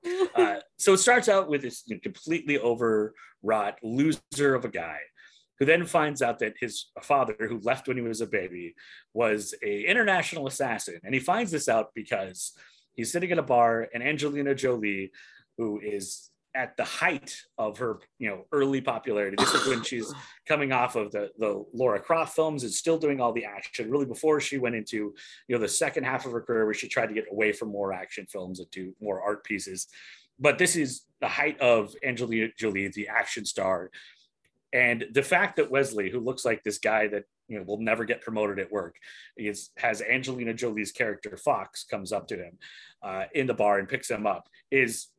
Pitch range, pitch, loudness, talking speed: 110-150 Hz, 125 Hz, -27 LUFS, 200 wpm